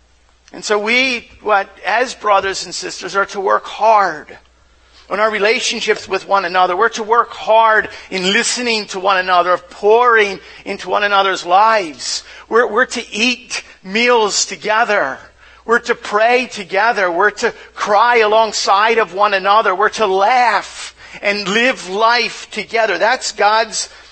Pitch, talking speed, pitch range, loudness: 215 Hz, 145 wpm, 195-230 Hz, -14 LUFS